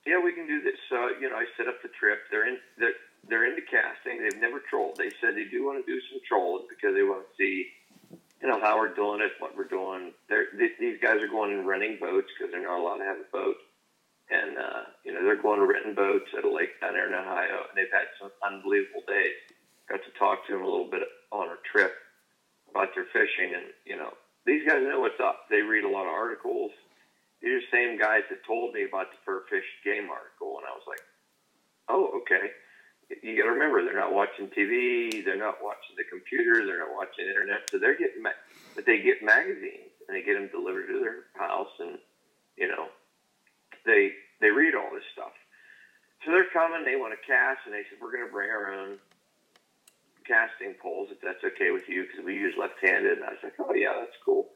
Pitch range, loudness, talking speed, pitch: 375-415 Hz, -28 LUFS, 230 wpm, 395 Hz